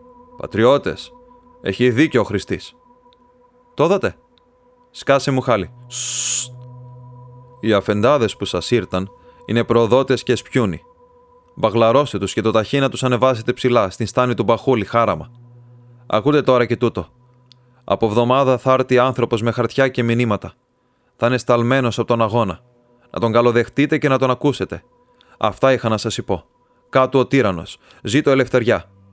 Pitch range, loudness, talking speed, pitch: 115-135 Hz, -18 LUFS, 140 wpm, 125 Hz